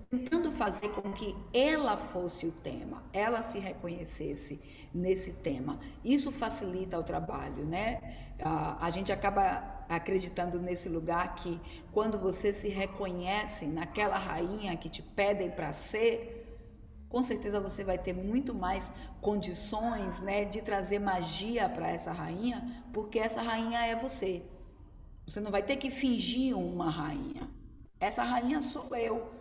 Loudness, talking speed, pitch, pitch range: -34 LUFS, 140 wpm, 200 Hz, 180-230 Hz